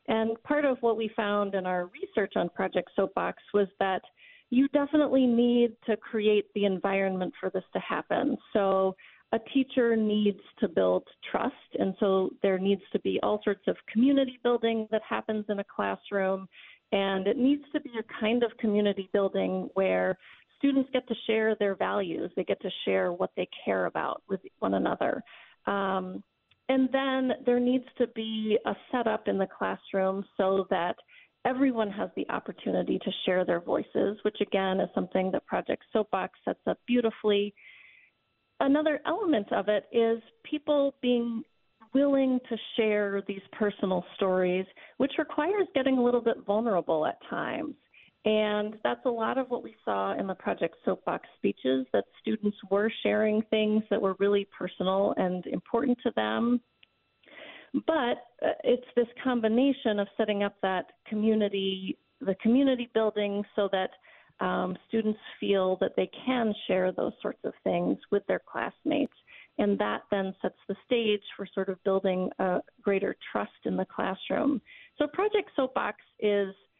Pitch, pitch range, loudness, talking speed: 215 Hz, 195-245 Hz, -29 LUFS, 160 wpm